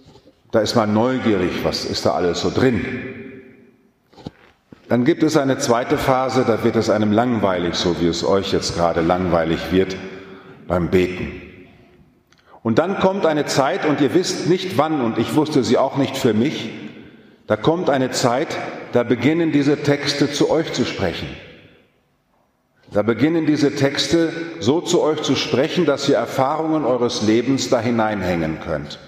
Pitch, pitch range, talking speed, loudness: 125 Hz, 105-145 Hz, 160 wpm, -19 LUFS